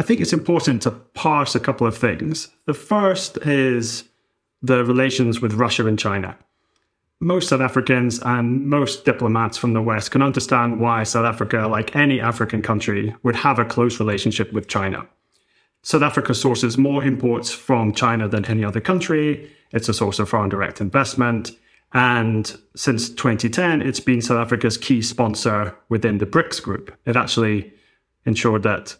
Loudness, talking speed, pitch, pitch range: -20 LUFS, 165 wpm, 120 Hz, 110-135 Hz